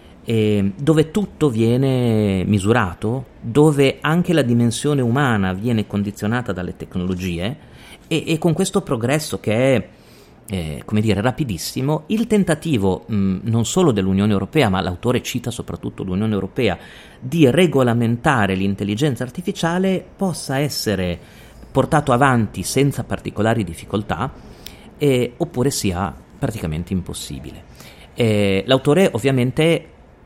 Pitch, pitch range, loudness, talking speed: 120 Hz, 100-145 Hz, -19 LUFS, 115 wpm